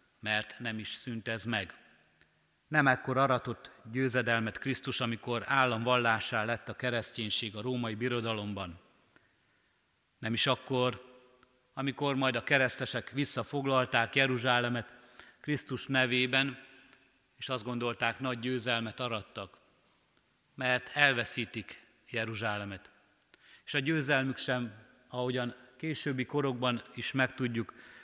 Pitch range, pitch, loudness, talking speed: 115-130 Hz, 125 Hz, -31 LUFS, 105 wpm